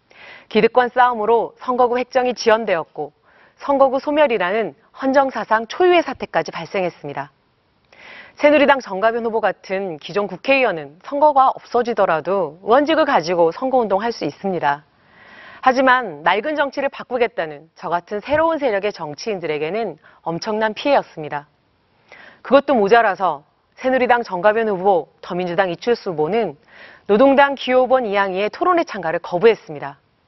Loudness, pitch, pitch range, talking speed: -18 LUFS, 215 Hz, 170-255 Hz, 340 characters per minute